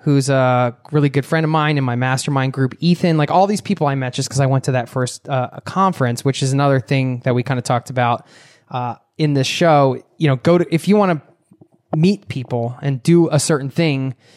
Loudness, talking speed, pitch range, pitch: -17 LUFS, 235 wpm, 130-160 Hz, 140 Hz